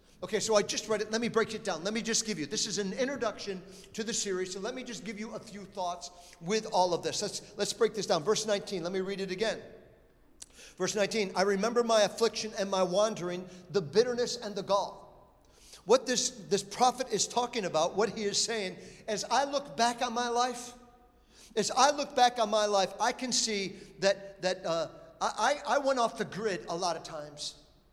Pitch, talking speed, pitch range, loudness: 210 Hz, 220 wpm, 195-230 Hz, -31 LUFS